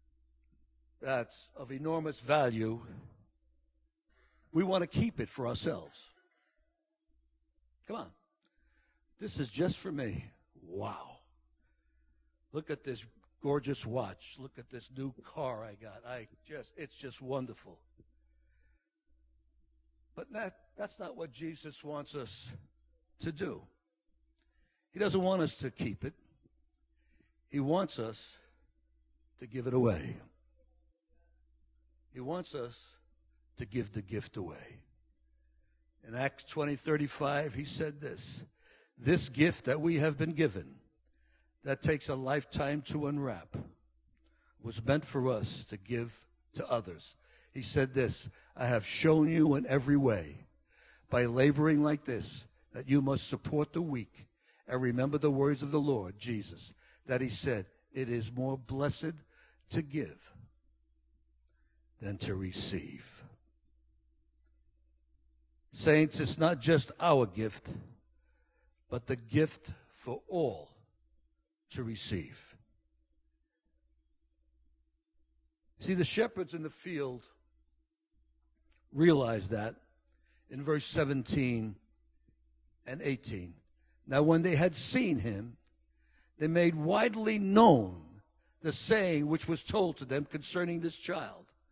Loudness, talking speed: -33 LUFS, 120 wpm